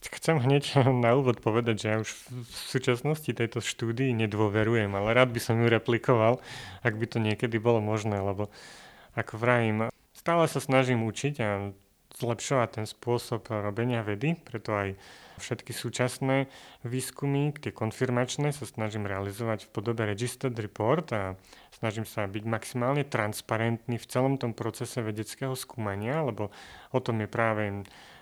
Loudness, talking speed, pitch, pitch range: -29 LUFS, 145 wpm, 115 Hz, 110-130 Hz